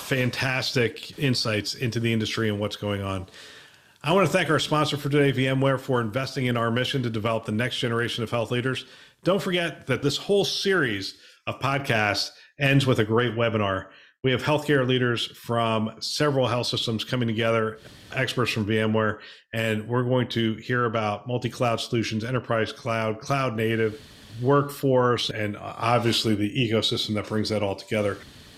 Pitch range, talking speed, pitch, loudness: 110-130 Hz, 170 wpm, 120 Hz, -25 LUFS